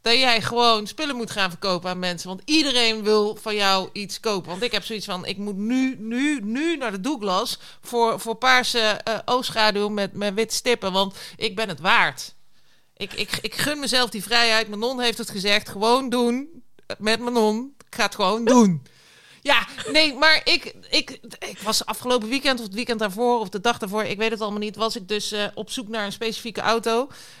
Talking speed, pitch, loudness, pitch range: 215 wpm, 225 Hz, -22 LUFS, 205-245 Hz